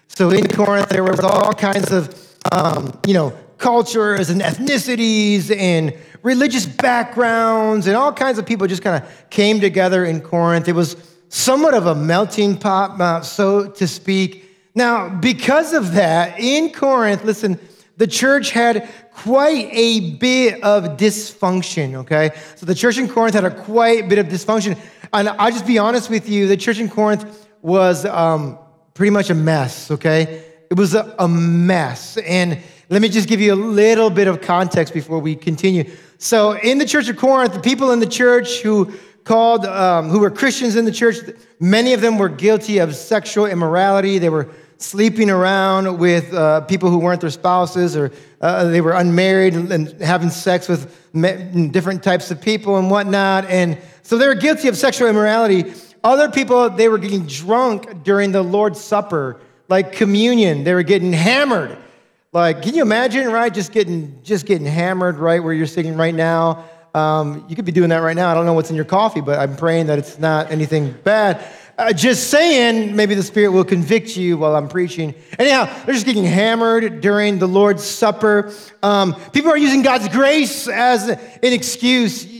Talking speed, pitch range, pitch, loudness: 185 wpm, 175-225 Hz, 195 Hz, -16 LUFS